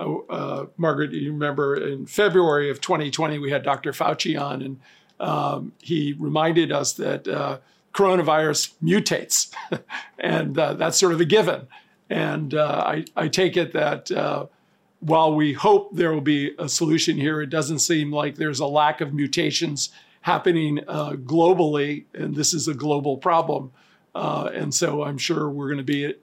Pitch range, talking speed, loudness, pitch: 145-165 Hz, 165 wpm, -22 LUFS, 155 Hz